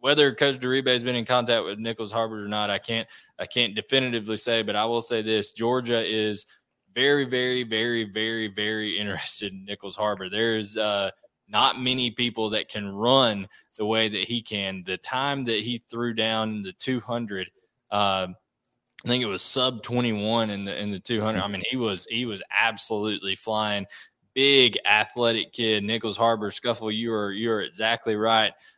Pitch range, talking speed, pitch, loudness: 105-120 Hz, 185 wpm, 110 Hz, -25 LUFS